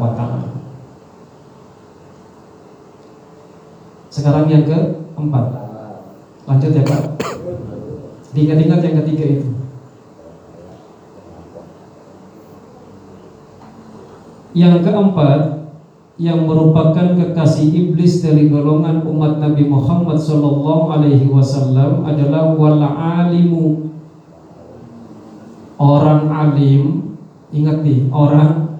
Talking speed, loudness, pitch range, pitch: 65 wpm, -13 LUFS, 145-160 Hz, 150 Hz